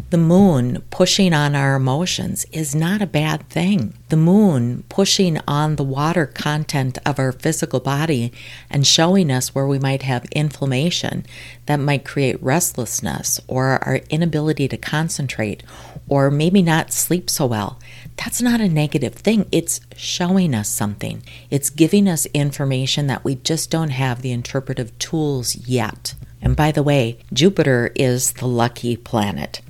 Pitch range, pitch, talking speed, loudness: 125-160 Hz, 140 Hz, 155 wpm, -18 LUFS